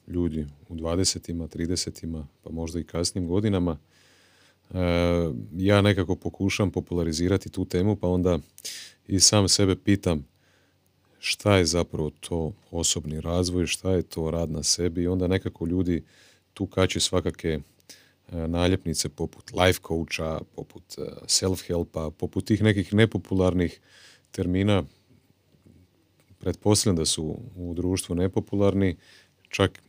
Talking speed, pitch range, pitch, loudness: 120 wpm, 85-95 Hz, 90 Hz, -25 LUFS